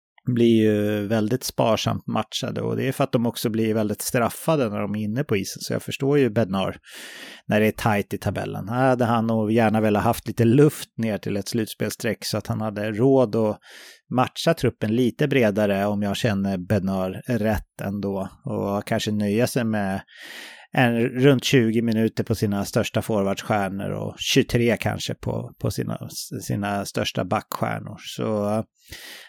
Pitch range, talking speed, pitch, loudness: 100-120 Hz, 170 wpm, 110 Hz, -23 LUFS